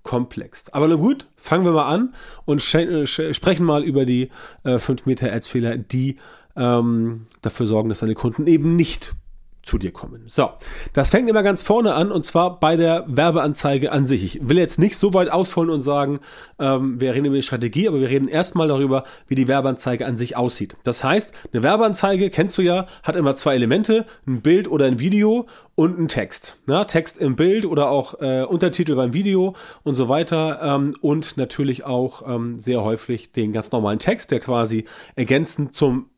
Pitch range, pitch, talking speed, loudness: 125-170 Hz, 145 Hz, 195 wpm, -20 LUFS